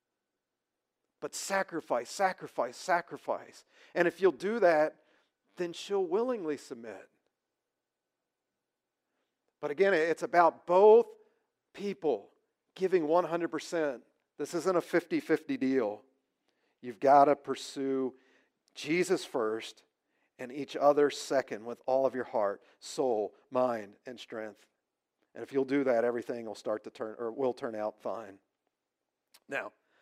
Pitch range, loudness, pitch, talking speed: 125-175 Hz, -31 LUFS, 145 Hz, 120 wpm